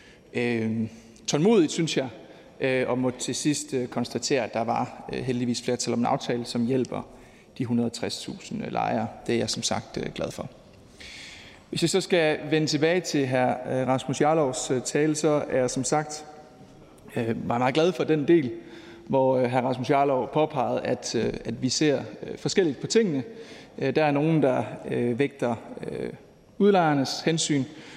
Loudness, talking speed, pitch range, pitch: -26 LUFS, 145 wpm, 125-155 Hz, 135 Hz